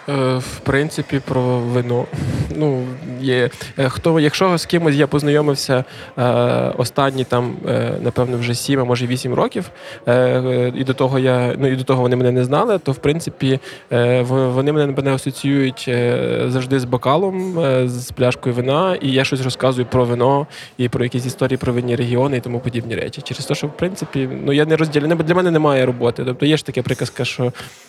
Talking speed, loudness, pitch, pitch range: 175 wpm, -18 LUFS, 130 Hz, 125-145 Hz